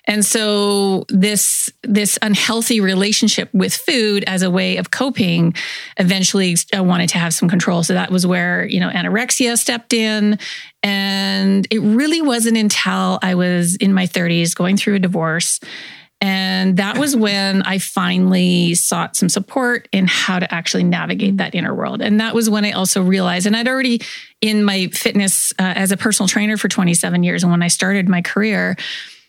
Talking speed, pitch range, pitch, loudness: 180 wpm, 185-215 Hz, 195 Hz, -16 LUFS